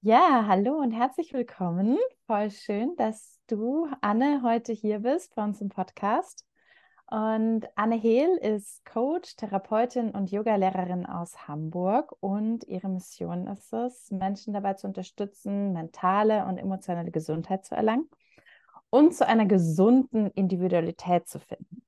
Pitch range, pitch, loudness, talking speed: 190-245 Hz, 215 Hz, -27 LUFS, 135 wpm